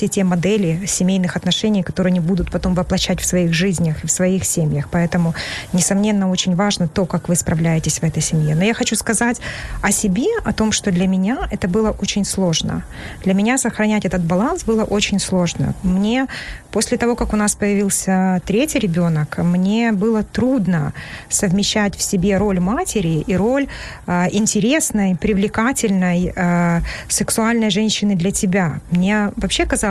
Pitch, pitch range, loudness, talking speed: 195 Hz, 180-215 Hz, -17 LUFS, 160 wpm